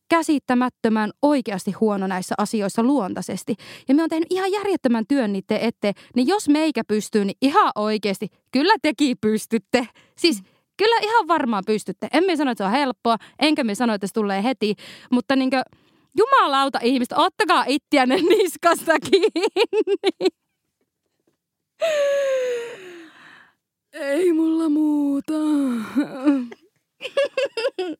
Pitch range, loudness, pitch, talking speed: 225-335 Hz, -21 LUFS, 280 Hz, 120 wpm